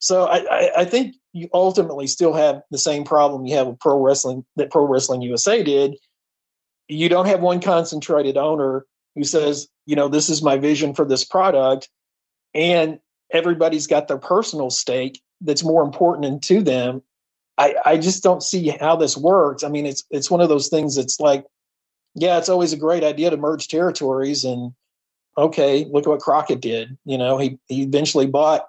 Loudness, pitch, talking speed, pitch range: -19 LUFS, 150 Hz, 190 wpm, 135-170 Hz